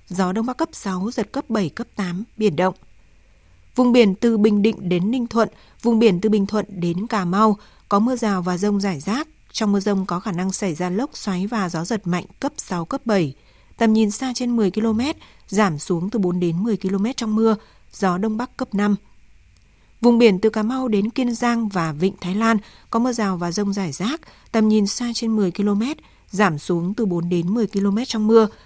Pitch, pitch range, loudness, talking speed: 210 Hz, 190-230 Hz, -21 LUFS, 225 wpm